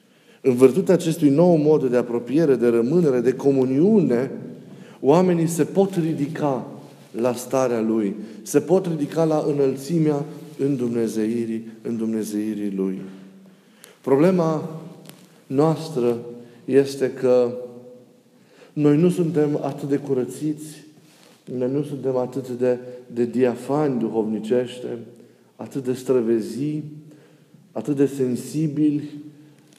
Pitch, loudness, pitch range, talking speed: 140 Hz, -21 LUFS, 120-155 Hz, 105 wpm